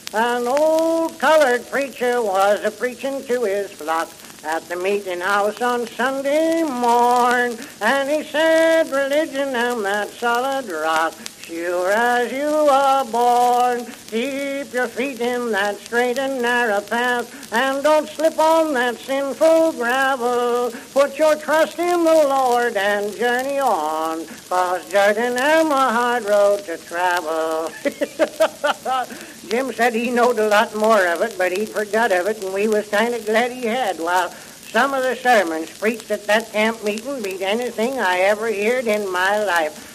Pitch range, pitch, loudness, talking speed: 205-270 Hz, 240 Hz, -19 LUFS, 155 wpm